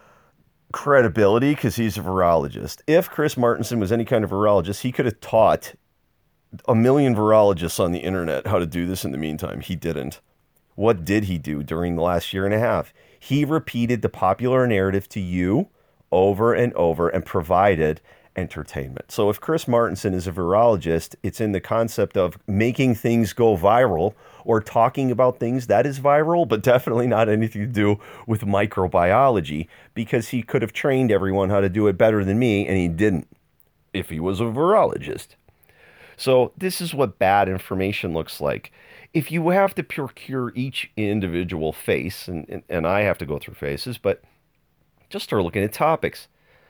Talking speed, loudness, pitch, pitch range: 180 wpm, -21 LUFS, 110 Hz, 95-125 Hz